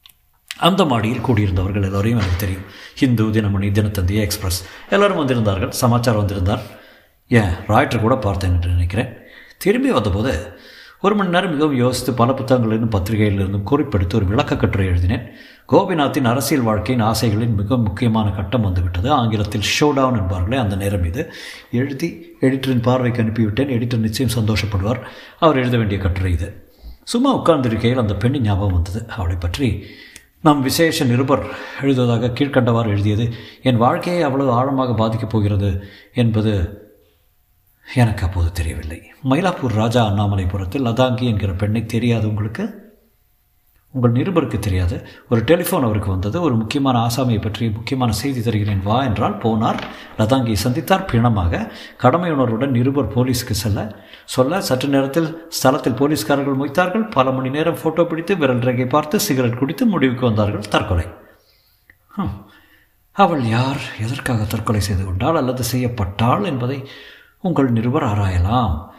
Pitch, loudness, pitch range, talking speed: 115 Hz, -18 LUFS, 105-135 Hz, 130 wpm